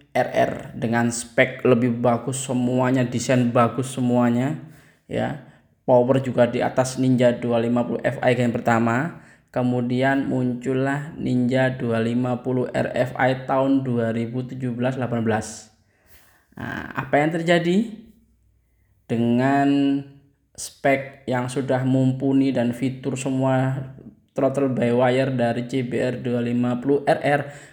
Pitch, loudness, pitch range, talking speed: 125 Hz, -22 LUFS, 120-135 Hz, 100 wpm